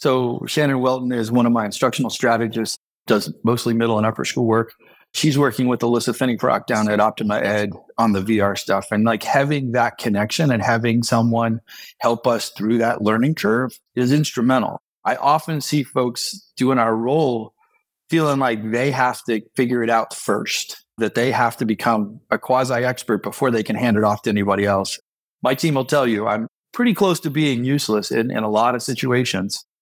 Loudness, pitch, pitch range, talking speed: -20 LUFS, 120 Hz, 110-130 Hz, 190 wpm